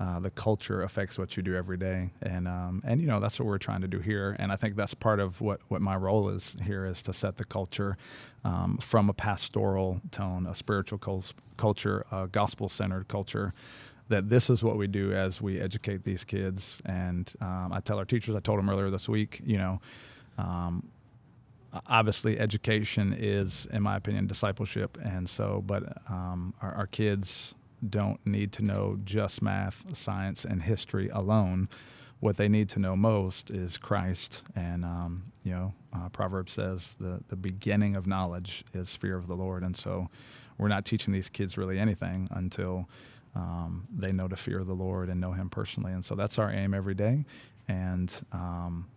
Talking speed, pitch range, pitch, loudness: 190 wpm, 95-110 Hz, 100 Hz, -31 LUFS